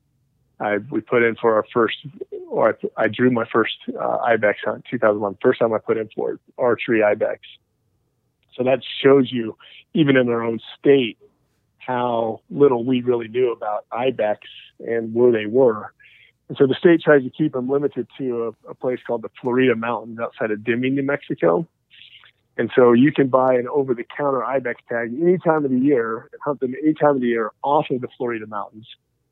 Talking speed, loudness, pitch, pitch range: 195 wpm, -20 LUFS, 125 Hz, 115-140 Hz